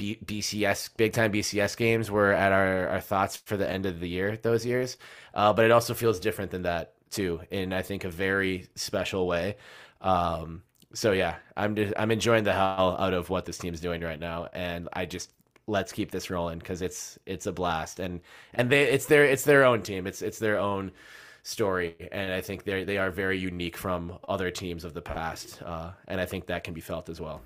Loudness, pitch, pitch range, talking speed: -28 LUFS, 95 Hz, 90-105 Hz, 220 wpm